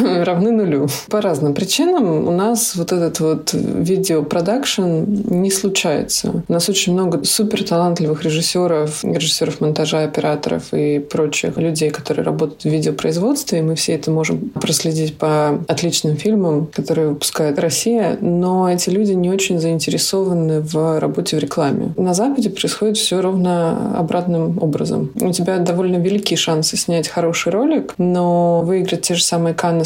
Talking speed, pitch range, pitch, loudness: 145 wpm, 155-190 Hz, 170 Hz, -17 LUFS